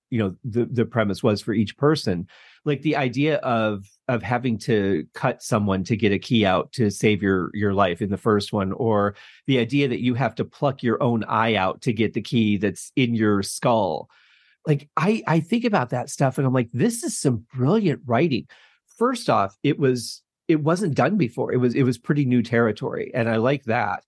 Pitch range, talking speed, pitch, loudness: 105-140 Hz, 215 wpm, 120 Hz, -22 LUFS